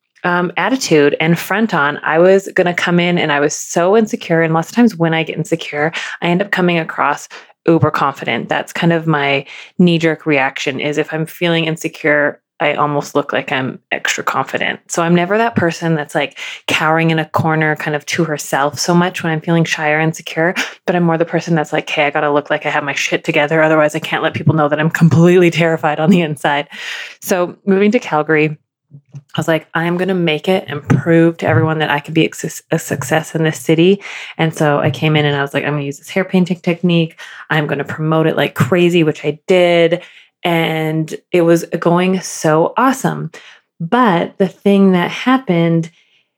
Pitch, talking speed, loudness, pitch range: 160 Hz, 215 wpm, -15 LUFS, 150-175 Hz